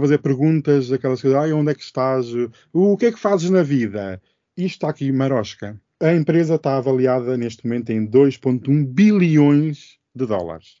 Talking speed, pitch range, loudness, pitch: 170 wpm, 125-155 Hz, -18 LUFS, 135 Hz